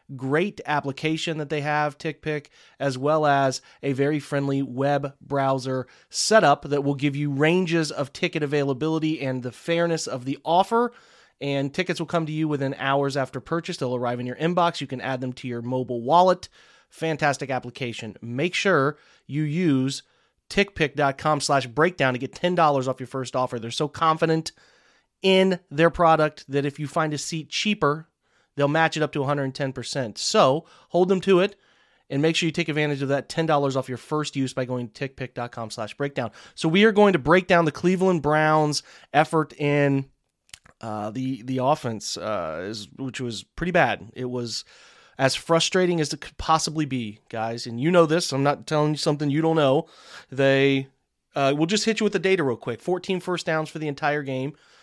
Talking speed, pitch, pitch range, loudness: 190 wpm, 145 Hz, 135-160 Hz, -24 LUFS